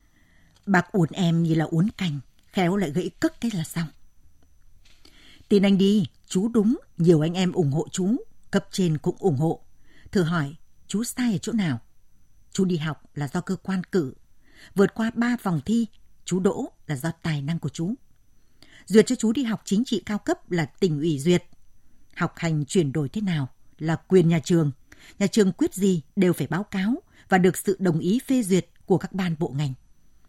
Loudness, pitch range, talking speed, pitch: -24 LUFS, 155-200 Hz, 200 wpm, 180 Hz